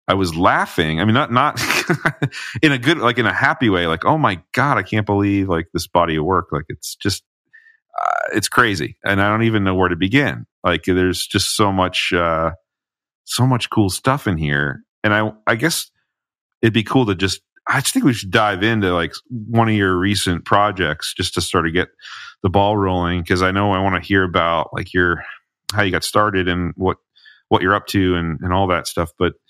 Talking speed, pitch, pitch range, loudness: 220 wpm, 100 Hz, 90-115 Hz, -18 LUFS